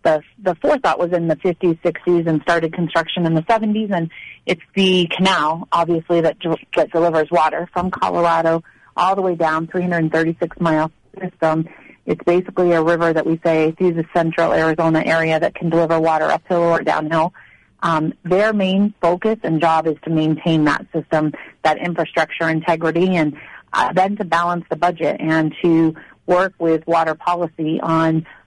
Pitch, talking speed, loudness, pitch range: 165 Hz, 160 wpm, -18 LUFS, 160-175 Hz